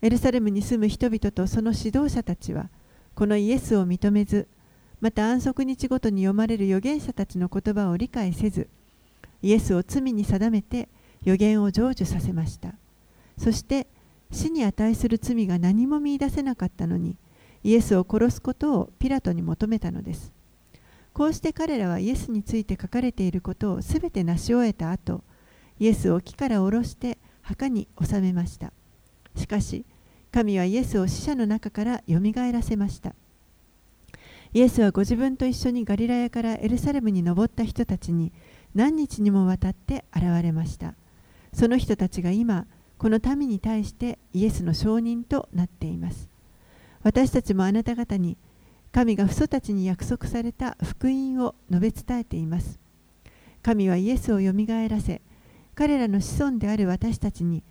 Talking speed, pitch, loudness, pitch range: 325 characters per minute, 215 Hz, -25 LUFS, 185-240 Hz